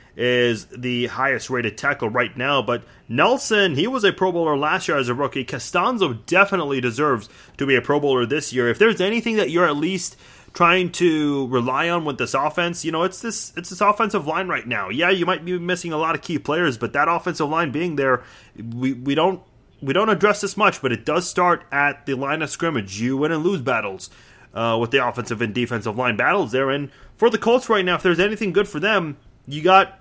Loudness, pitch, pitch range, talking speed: -20 LUFS, 150 Hz, 130-185 Hz, 220 wpm